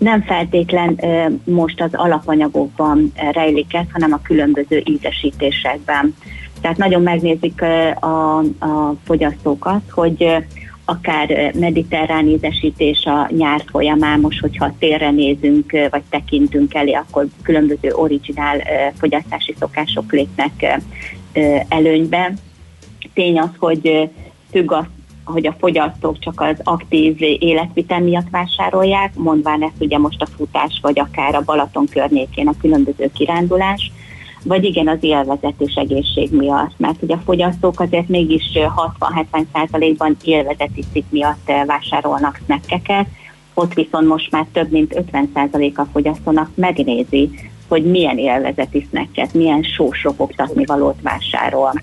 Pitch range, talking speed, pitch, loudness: 145-170 Hz, 120 wpm, 155 Hz, -16 LUFS